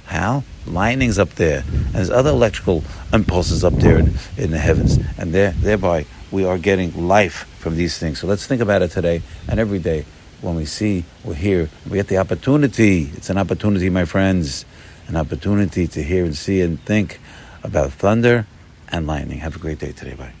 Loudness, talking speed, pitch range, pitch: -19 LUFS, 195 wpm, 80-100 Hz, 90 Hz